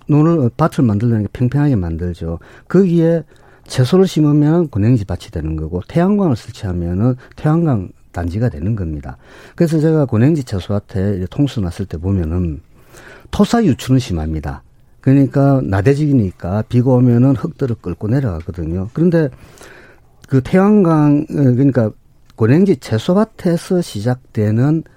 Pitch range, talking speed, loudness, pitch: 100-150 Hz, 325 characters per minute, -15 LUFS, 125 Hz